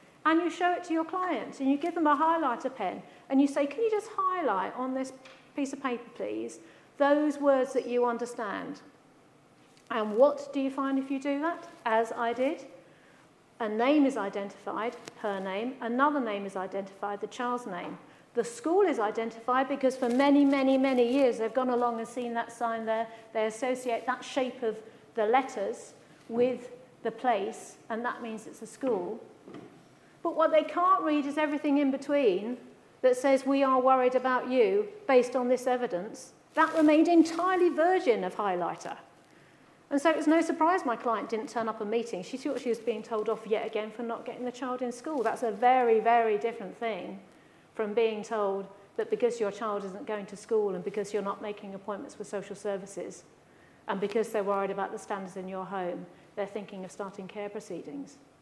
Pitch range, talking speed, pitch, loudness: 220-280 Hz, 195 wpm, 245 Hz, -29 LUFS